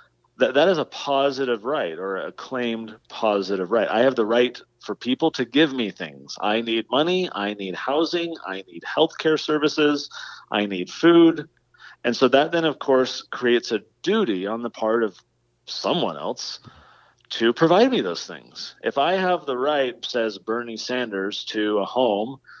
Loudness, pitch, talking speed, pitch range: -22 LUFS, 120 Hz, 175 wpm, 105-150 Hz